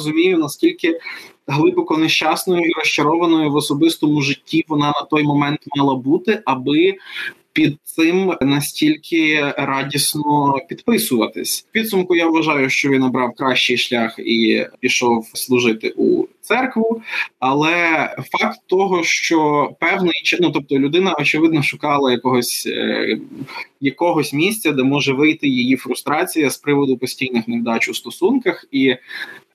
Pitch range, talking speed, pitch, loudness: 135-180 Hz, 120 wpm, 150 Hz, -17 LUFS